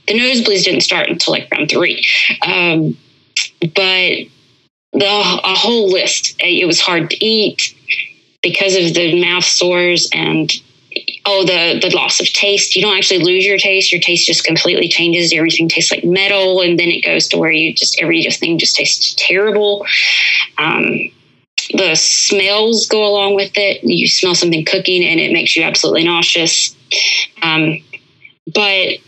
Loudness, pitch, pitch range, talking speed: -11 LUFS, 180 Hz, 170-200 Hz, 160 wpm